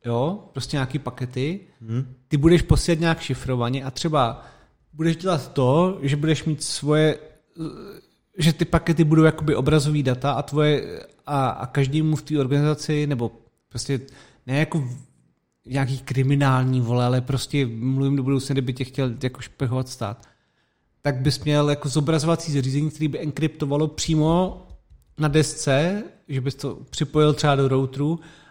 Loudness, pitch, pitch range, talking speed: -22 LUFS, 145 Hz, 130-155 Hz, 145 wpm